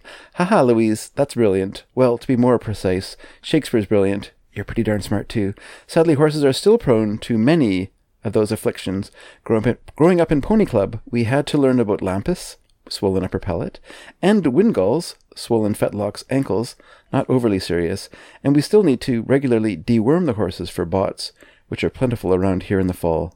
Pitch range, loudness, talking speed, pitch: 95-135 Hz, -19 LUFS, 175 wpm, 115 Hz